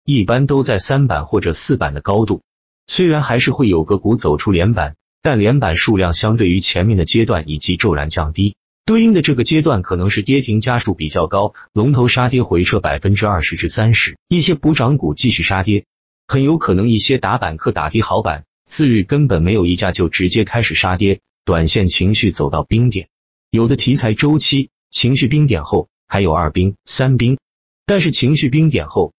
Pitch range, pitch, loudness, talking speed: 90-135 Hz, 110 Hz, -15 LUFS, 295 characters per minute